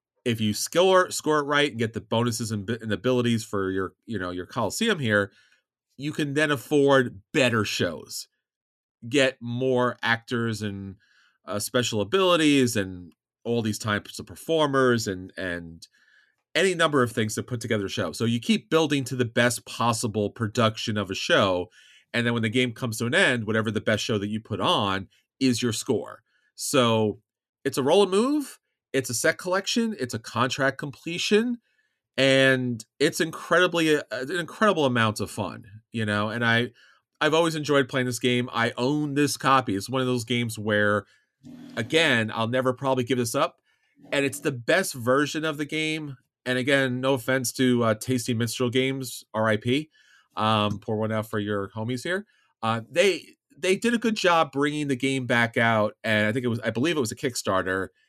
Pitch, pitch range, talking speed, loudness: 125 Hz, 110-140 Hz, 185 wpm, -25 LUFS